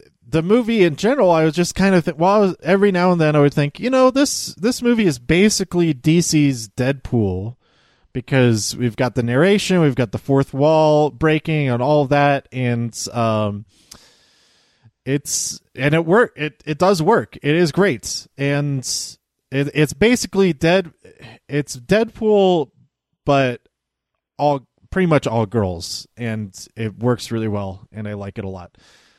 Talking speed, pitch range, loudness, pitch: 160 wpm, 120-175 Hz, -18 LUFS, 145 Hz